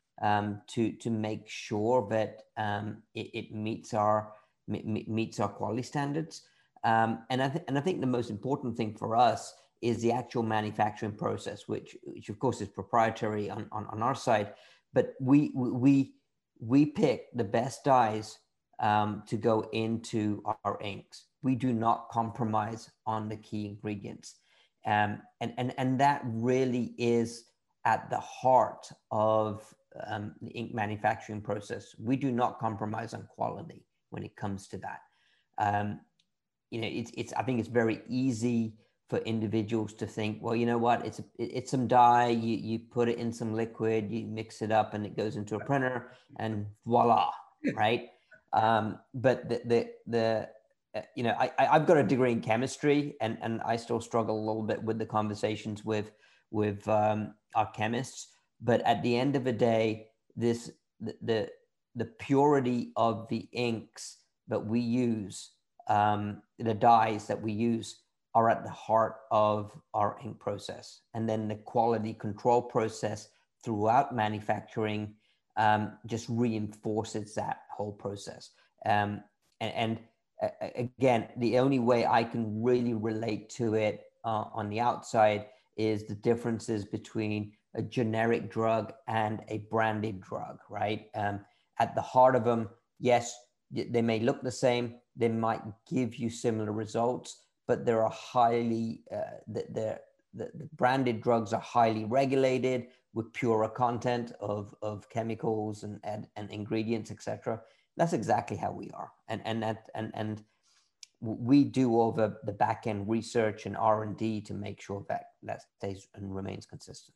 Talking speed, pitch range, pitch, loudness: 165 wpm, 105-120 Hz, 110 Hz, -31 LUFS